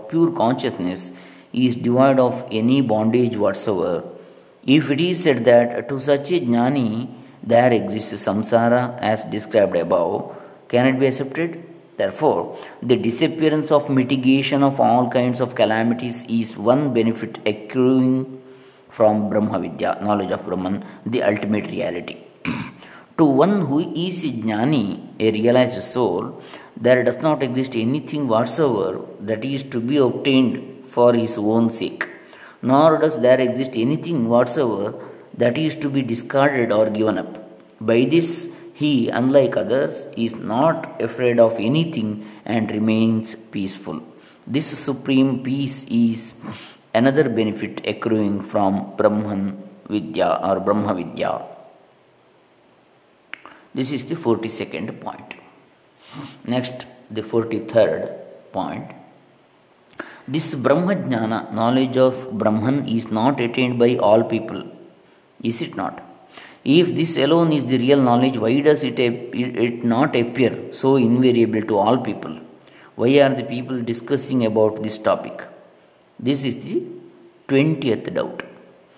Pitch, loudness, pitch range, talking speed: 125 Hz, -20 LUFS, 110-135 Hz, 130 wpm